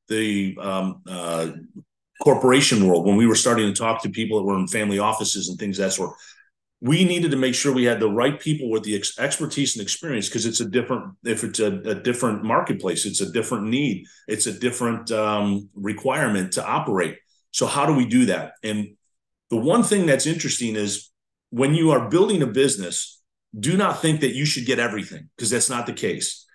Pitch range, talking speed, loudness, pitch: 100-140 Hz, 210 wpm, -22 LUFS, 115 Hz